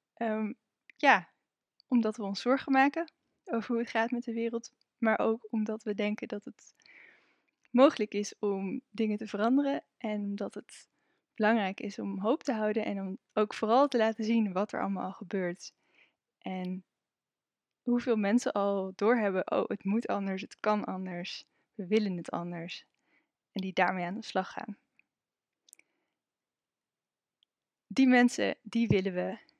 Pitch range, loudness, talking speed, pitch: 200-235 Hz, -31 LUFS, 155 wpm, 215 Hz